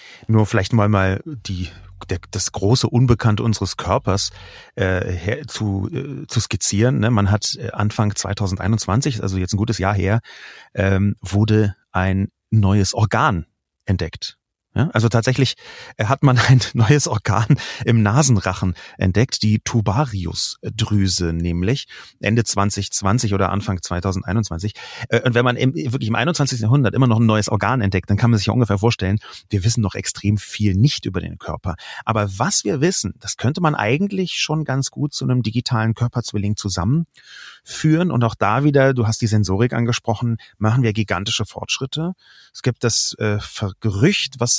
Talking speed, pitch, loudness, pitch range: 160 wpm, 110 Hz, -19 LUFS, 100-125 Hz